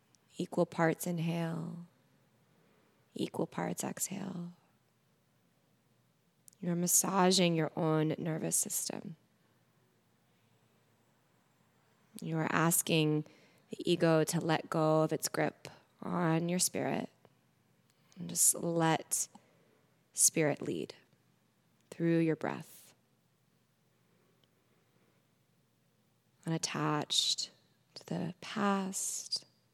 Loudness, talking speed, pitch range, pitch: -32 LUFS, 75 wpm, 160-175 Hz, 165 Hz